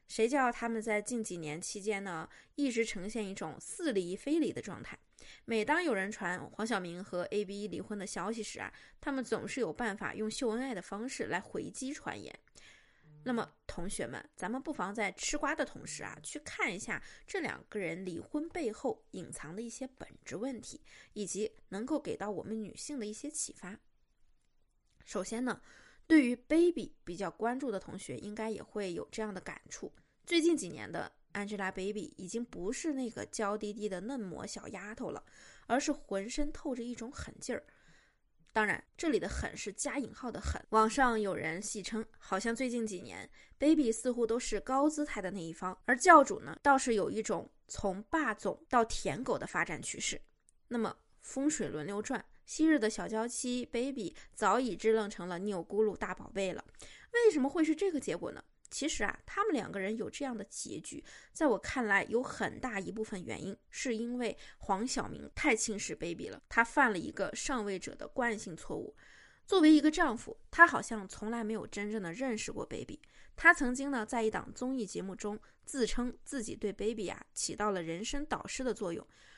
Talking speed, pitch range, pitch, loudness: 295 characters per minute, 205-265 Hz, 225 Hz, -35 LUFS